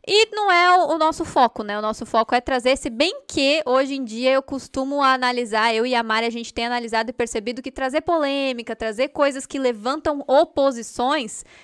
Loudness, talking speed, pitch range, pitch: -21 LUFS, 200 wpm, 235-295 Hz, 265 Hz